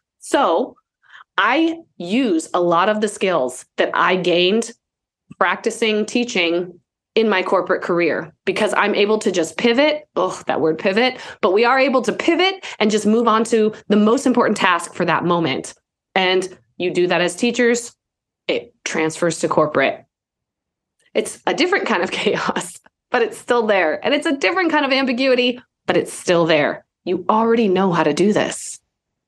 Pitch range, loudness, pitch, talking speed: 175-245 Hz, -18 LUFS, 210 Hz, 170 wpm